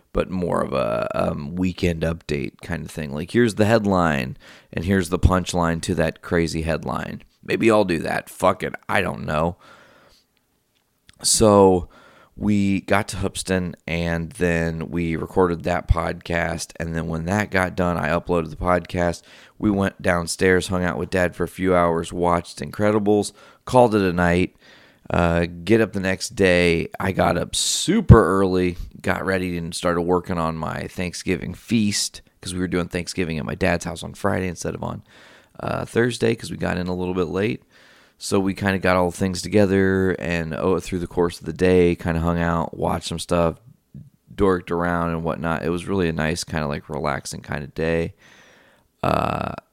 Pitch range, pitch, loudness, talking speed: 85-95 Hz, 90 Hz, -22 LUFS, 185 wpm